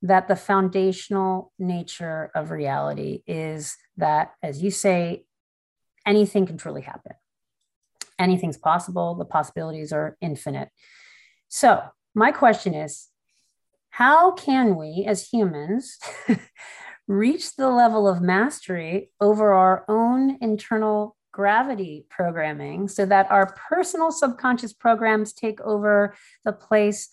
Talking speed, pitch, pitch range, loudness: 115 wpm, 195 Hz, 170-215 Hz, -22 LUFS